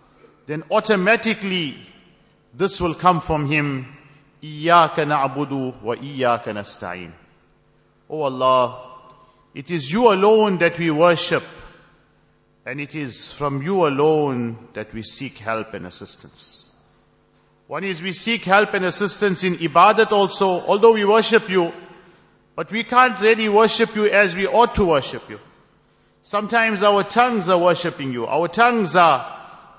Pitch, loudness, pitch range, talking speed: 170 Hz, -18 LUFS, 140-205 Hz, 135 wpm